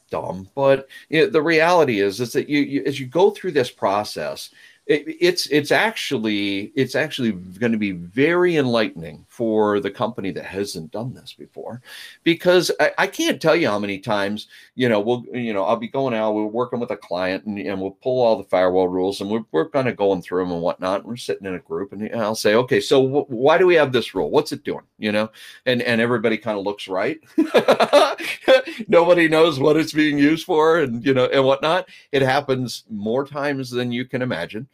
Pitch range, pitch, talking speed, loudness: 105-150 Hz, 125 Hz, 220 wpm, -20 LUFS